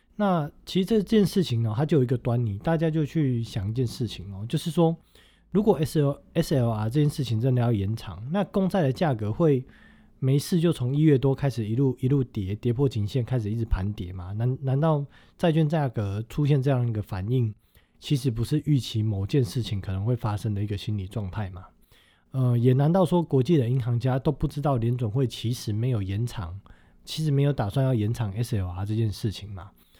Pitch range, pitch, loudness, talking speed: 110-145 Hz, 125 Hz, -26 LUFS, 310 characters per minute